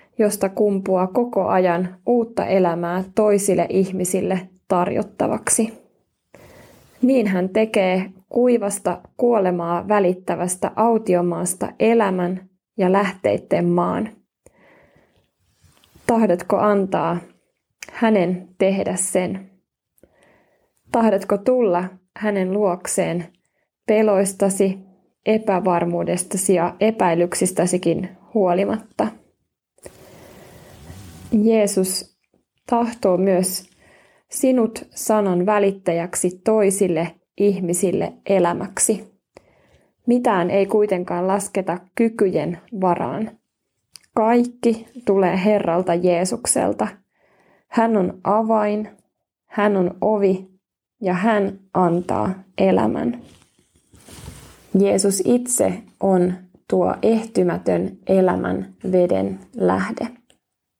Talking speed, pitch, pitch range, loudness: 70 wpm, 195 Hz, 180-215 Hz, -20 LUFS